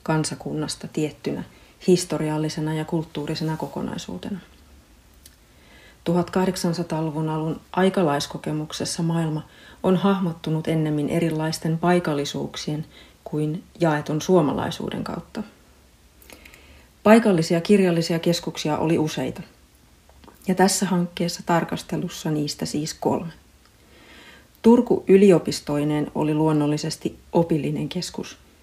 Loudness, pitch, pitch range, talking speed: -23 LUFS, 160 Hz, 150-175 Hz, 80 wpm